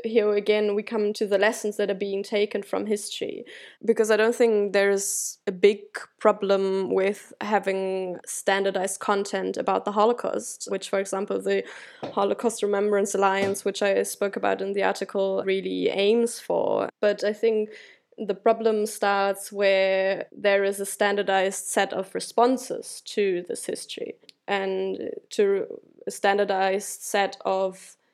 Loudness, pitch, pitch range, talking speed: -25 LUFS, 205 Hz, 195-225 Hz, 145 wpm